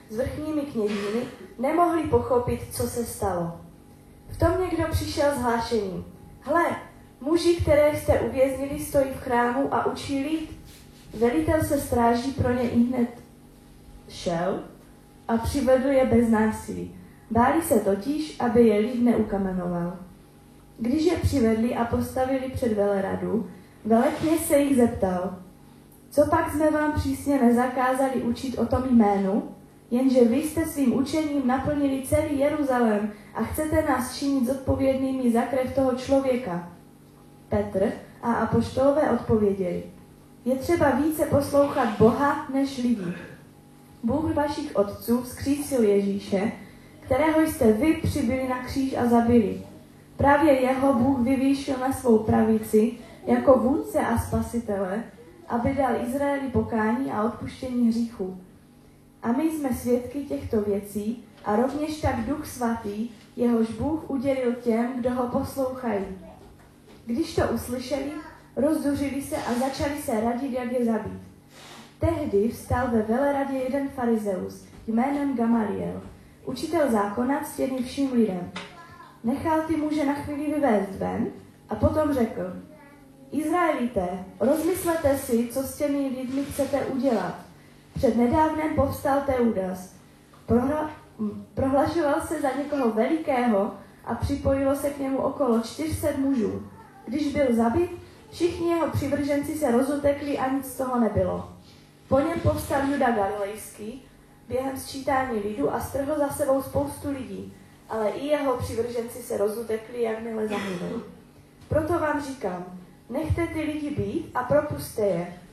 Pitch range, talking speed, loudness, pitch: 220-285 Hz, 130 wpm, -25 LUFS, 255 Hz